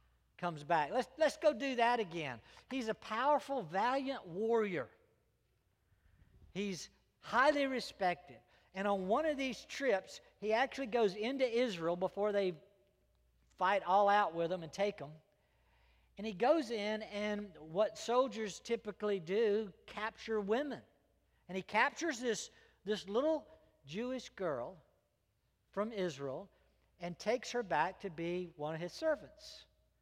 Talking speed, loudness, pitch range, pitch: 135 wpm, -37 LUFS, 170-240 Hz, 205 Hz